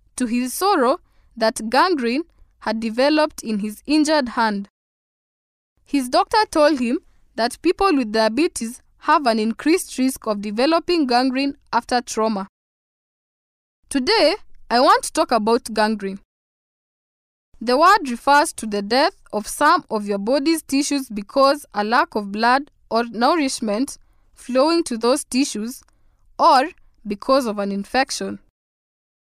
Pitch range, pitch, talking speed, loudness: 220-295 Hz, 255 Hz, 130 wpm, -19 LUFS